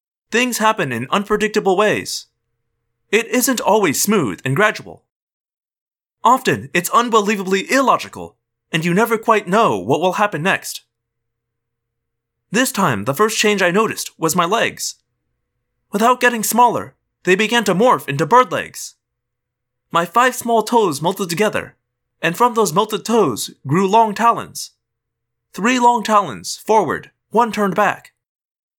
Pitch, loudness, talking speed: 195 Hz, -16 LUFS, 135 wpm